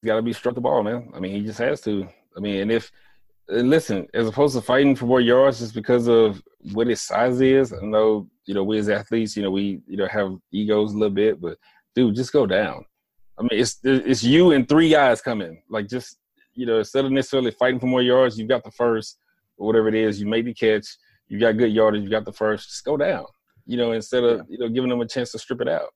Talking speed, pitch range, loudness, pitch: 255 wpm, 105-125 Hz, -21 LUFS, 115 Hz